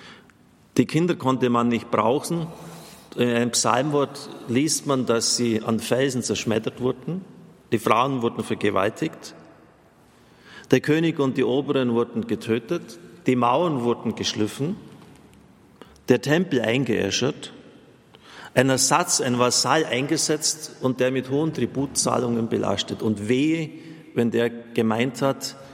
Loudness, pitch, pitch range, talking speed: -23 LUFS, 125 Hz, 115-145 Hz, 120 wpm